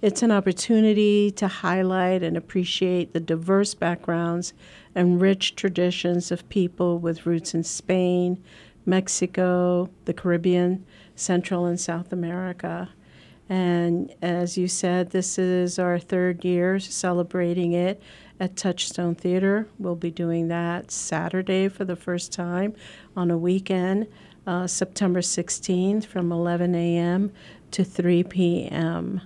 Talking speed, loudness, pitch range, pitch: 125 wpm, -24 LUFS, 175-190 Hz, 180 Hz